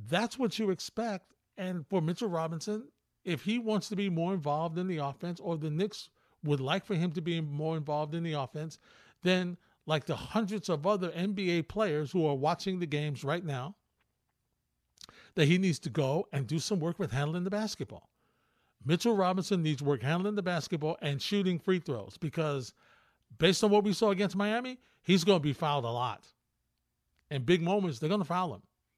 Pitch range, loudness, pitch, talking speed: 150-195 Hz, -32 LUFS, 175 Hz, 195 wpm